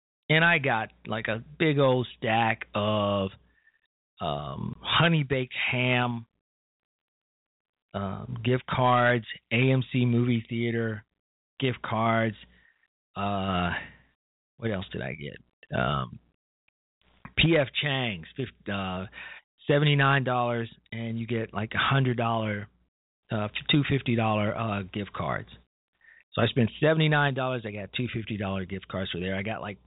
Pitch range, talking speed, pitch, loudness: 100-130 Hz, 110 wpm, 115 Hz, -27 LUFS